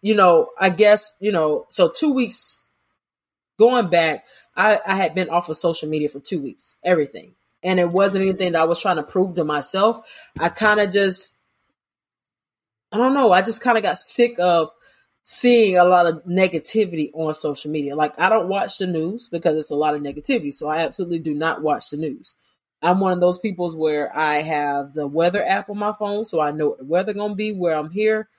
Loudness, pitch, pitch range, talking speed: -19 LUFS, 180 Hz, 155-210 Hz, 220 wpm